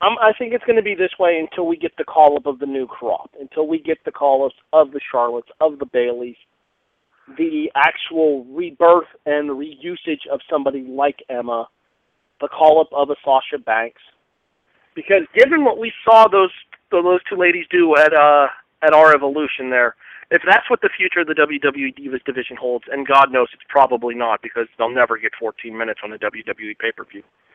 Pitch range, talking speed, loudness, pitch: 125-175 Hz, 185 wpm, -17 LUFS, 145 Hz